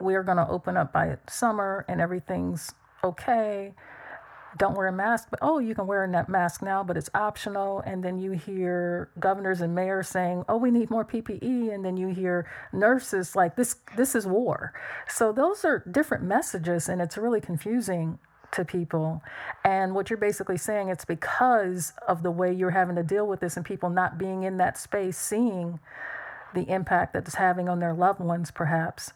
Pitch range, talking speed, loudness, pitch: 180-210 Hz, 200 wpm, -27 LUFS, 190 Hz